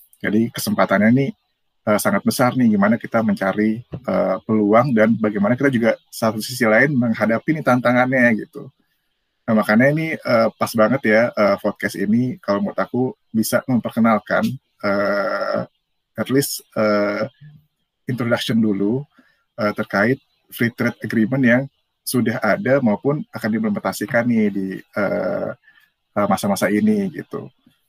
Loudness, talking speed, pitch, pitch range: -19 LUFS, 135 wpm, 115 Hz, 105-130 Hz